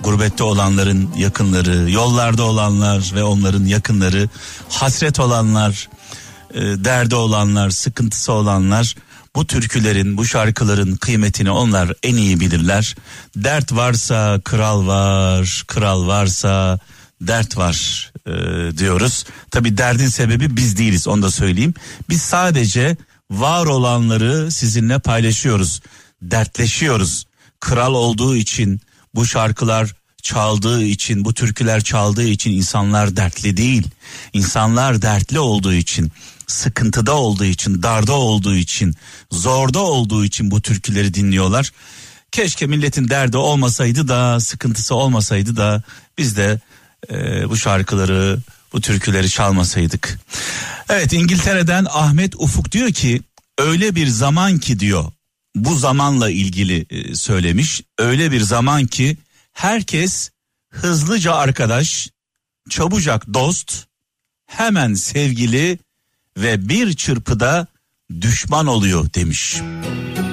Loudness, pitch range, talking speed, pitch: -16 LUFS, 100-130 Hz, 110 wpm, 115 Hz